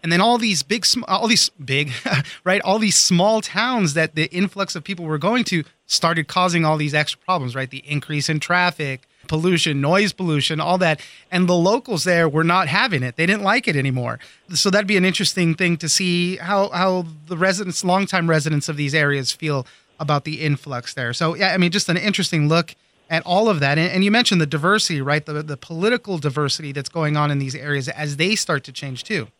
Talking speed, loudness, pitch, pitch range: 215 wpm, -19 LUFS, 165 Hz, 150-190 Hz